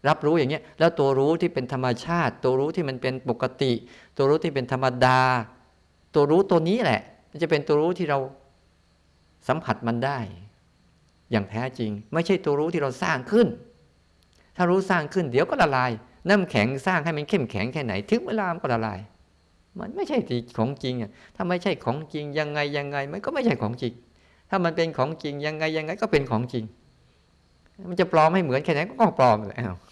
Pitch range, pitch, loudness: 115-165 Hz, 135 Hz, -24 LUFS